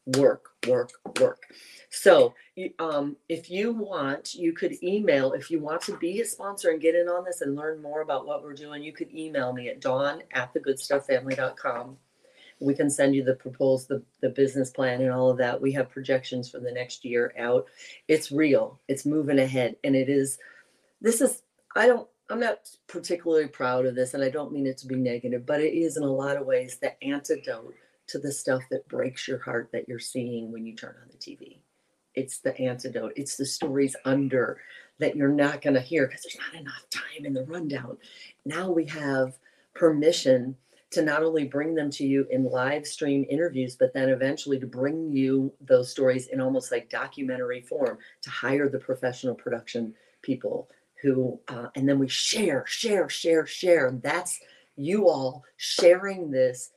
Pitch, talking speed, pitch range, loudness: 140 Hz, 195 wpm, 130-165 Hz, -27 LUFS